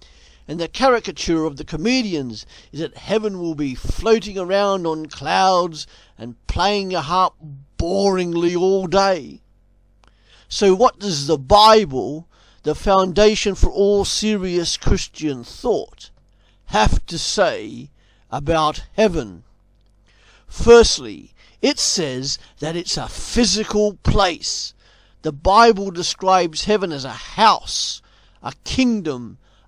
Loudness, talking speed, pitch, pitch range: -18 LUFS, 115 wpm, 170 Hz, 145-200 Hz